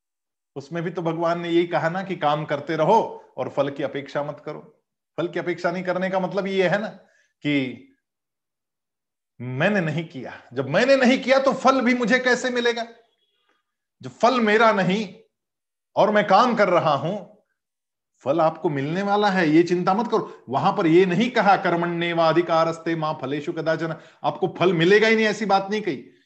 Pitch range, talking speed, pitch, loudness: 160-215 Hz, 180 wpm, 185 Hz, -21 LUFS